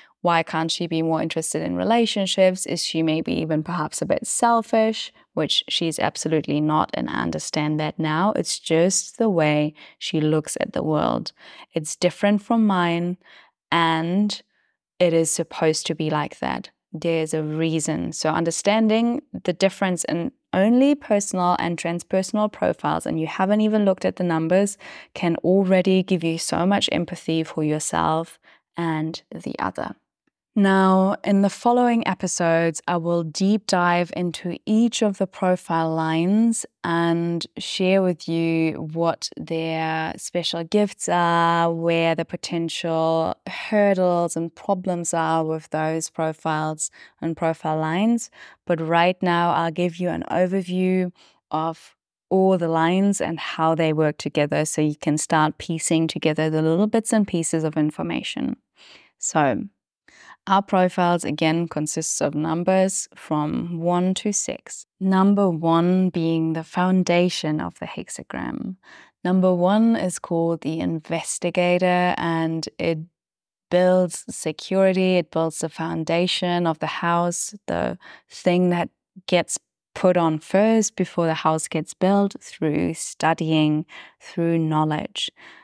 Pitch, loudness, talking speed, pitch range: 170 Hz, -22 LUFS, 140 wpm, 160-190 Hz